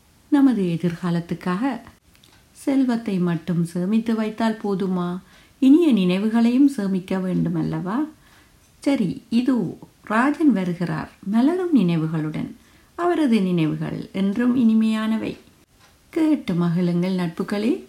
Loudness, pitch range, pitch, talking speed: -21 LUFS, 180-260 Hz, 210 Hz, 85 wpm